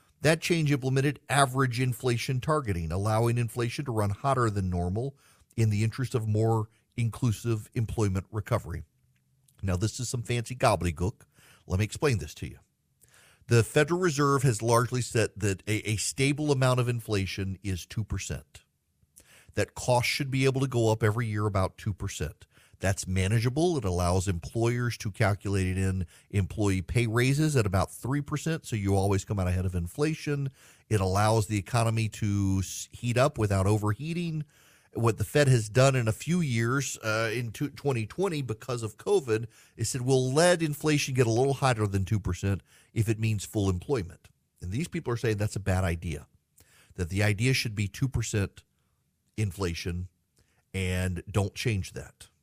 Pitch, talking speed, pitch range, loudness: 110 Hz, 165 wpm, 100-130 Hz, -28 LUFS